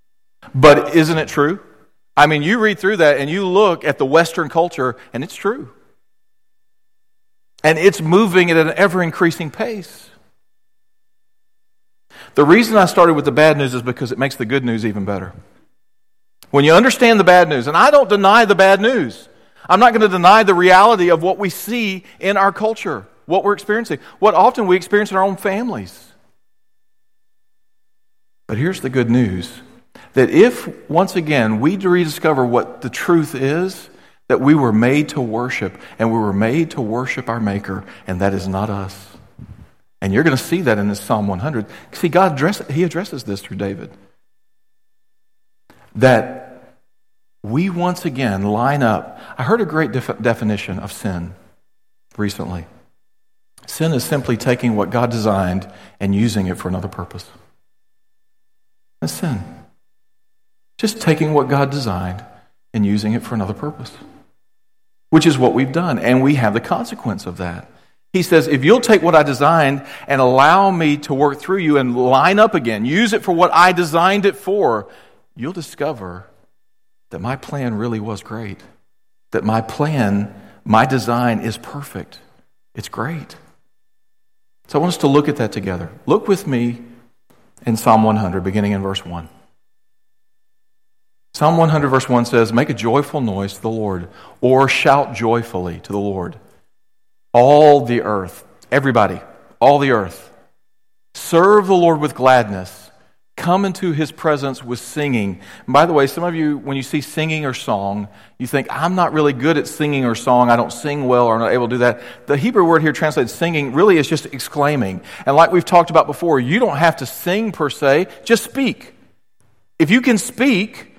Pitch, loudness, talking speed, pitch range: 140 Hz, -15 LUFS, 170 wpm, 115-170 Hz